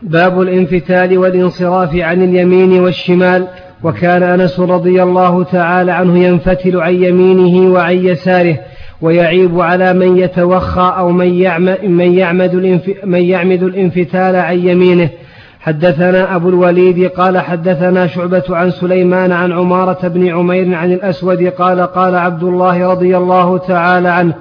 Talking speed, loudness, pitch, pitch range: 135 wpm, -10 LUFS, 180 Hz, 180-185 Hz